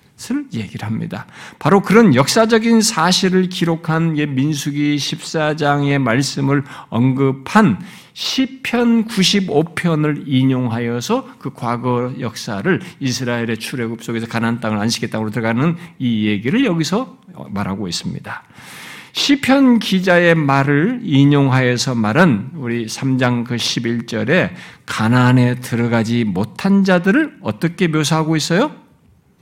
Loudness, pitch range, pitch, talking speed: -16 LUFS, 120-185 Hz, 145 Hz, 260 characters per minute